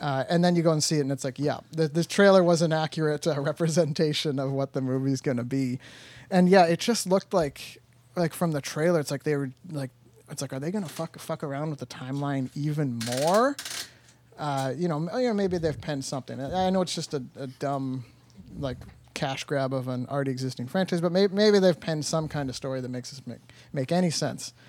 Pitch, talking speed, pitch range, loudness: 150 Hz, 235 wpm, 130-170 Hz, -27 LUFS